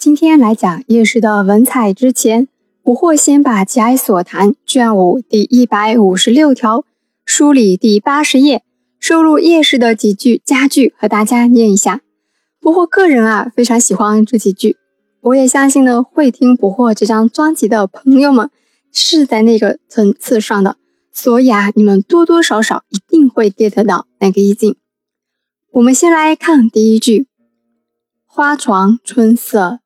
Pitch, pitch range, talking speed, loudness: 230 Hz, 210-275 Hz, 235 characters per minute, -10 LUFS